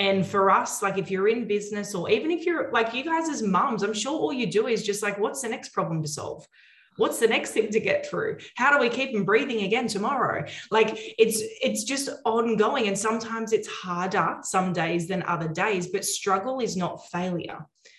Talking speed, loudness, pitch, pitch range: 215 wpm, -25 LUFS, 215 Hz, 195-235 Hz